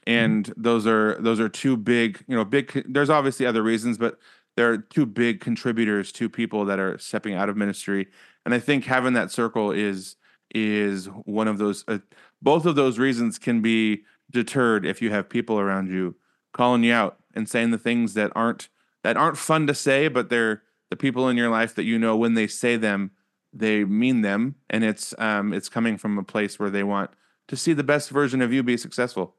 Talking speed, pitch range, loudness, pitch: 210 wpm, 105-125 Hz, -23 LUFS, 115 Hz